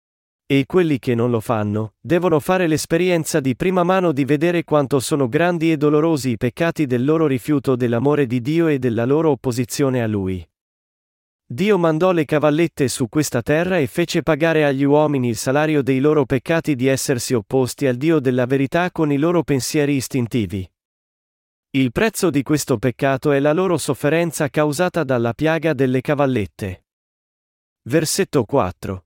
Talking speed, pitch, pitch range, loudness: 160 wpm, 145 Hz, 125-160 Hz, -18 LUFS